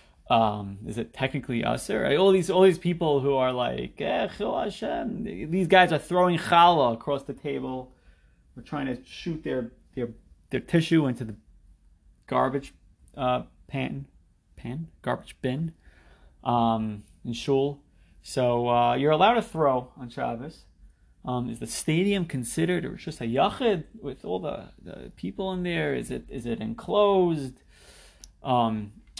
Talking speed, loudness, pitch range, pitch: 150 wpm, -26 LUFS, 110-160 Hz, 130 Hz